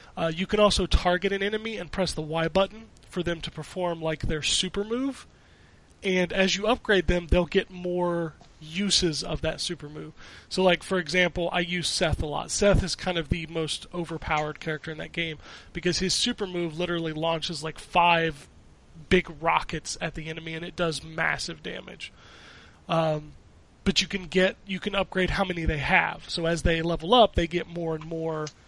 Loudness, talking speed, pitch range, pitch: -26 LUFS, 195 wpm, 160-185 Hz, 175 Hz